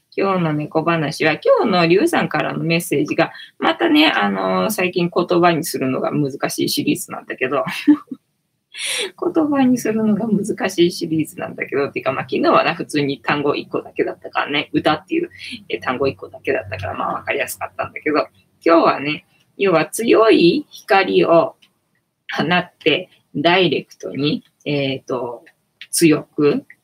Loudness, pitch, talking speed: -18 LUFS, 170 Hz, 325 characters per minute